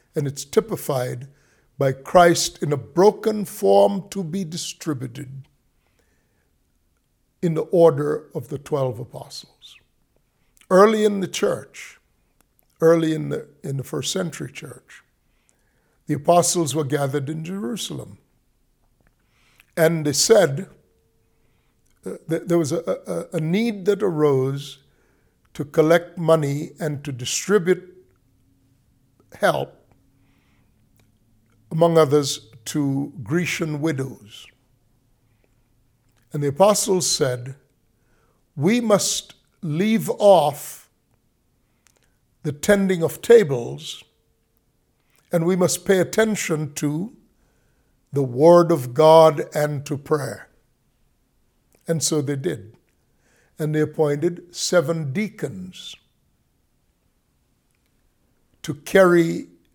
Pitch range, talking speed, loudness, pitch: 130-175 Hz, 95 wpm, -20 LUFS, 150 Hz